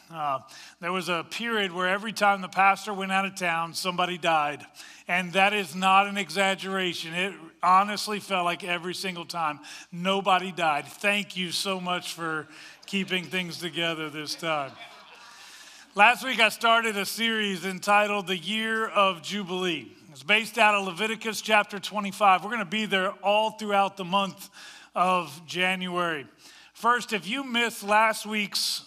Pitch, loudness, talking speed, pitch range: 195 Hz, -25 LUFS, 160 wpm, 180-210 Hz